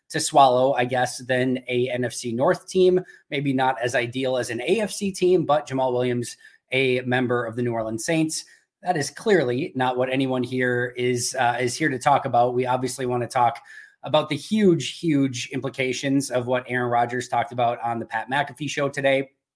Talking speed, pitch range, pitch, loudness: 195 wpm, 125-140 Hz, 130 Hz, -23 LUFS